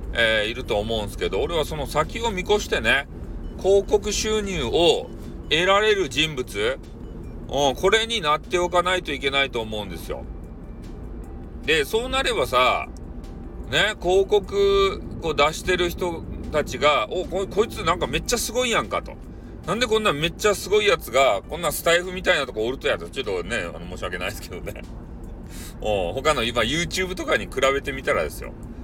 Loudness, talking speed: -22 LUFS, 350 characters per minute